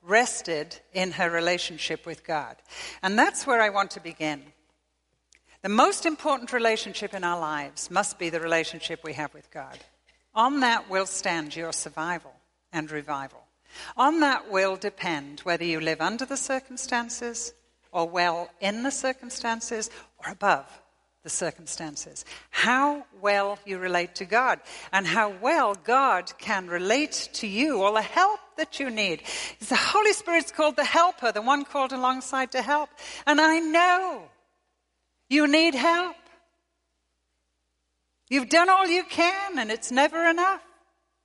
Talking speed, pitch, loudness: 150 wpm, 225 Hz, -25 LUFS